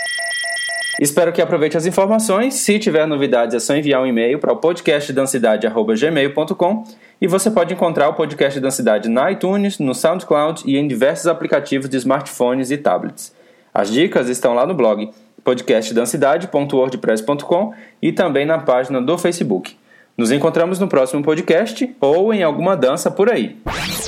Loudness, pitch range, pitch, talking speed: -17 LUFS, 135-195 Hz, 160 Hz, 145 wpm